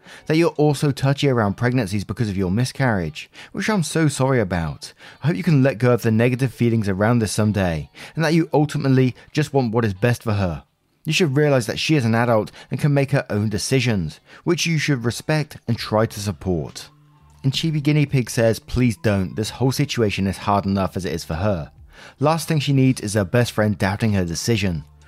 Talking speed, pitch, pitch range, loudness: 215 wpm, 120 Hz, 105-145 Hz, -20 LUFS